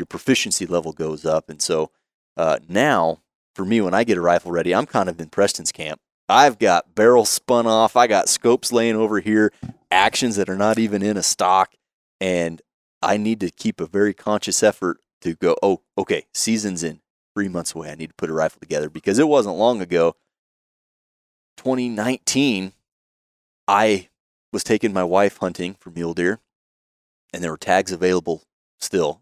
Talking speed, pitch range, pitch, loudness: 180 wpm, 85-110 Hz, 95 Hz, -20 LUFS